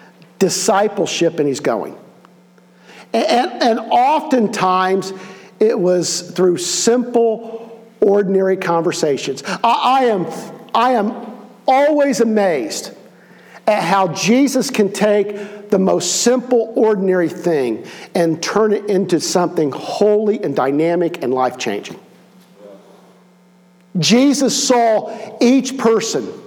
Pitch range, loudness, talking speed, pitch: 180-235 Hz, -16 LUFS, 105 wpm, 205 Hz